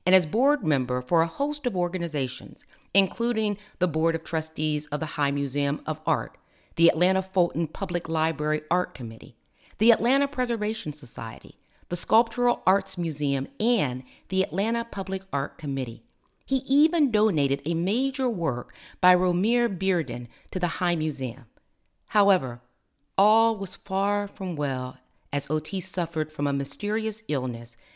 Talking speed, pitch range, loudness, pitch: 145 wpm, 145-205 Hz, -26 LUFS, 175 Hz